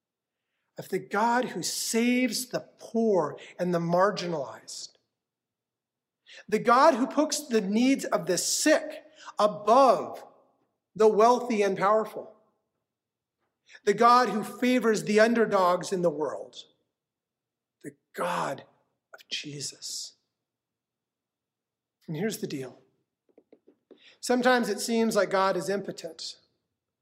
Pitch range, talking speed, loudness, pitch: 175-240 Hz, 105 wpm, -26 LUFS, 210 Hz